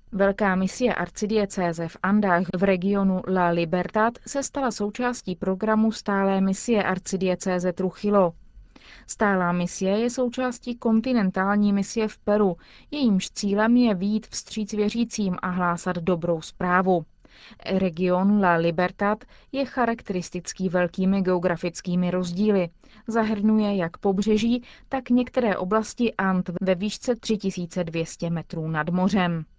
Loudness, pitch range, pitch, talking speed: -24 LUFS, 180-220 Hz, 195 Hz, 120 wpm